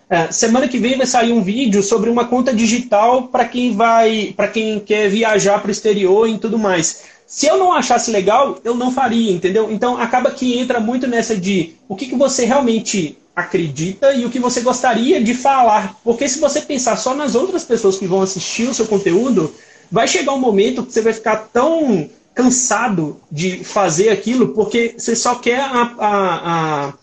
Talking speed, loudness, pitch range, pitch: 195 wpm, -15 LUFS, 205-250 Hz, 230 Hz